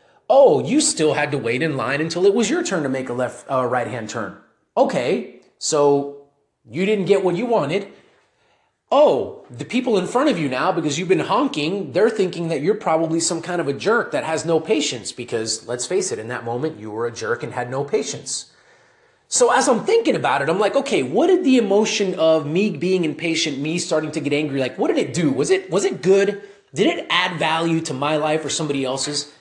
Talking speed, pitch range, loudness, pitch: 230 wpm, 145-200 Hz, -20 LUFS, 165 Hz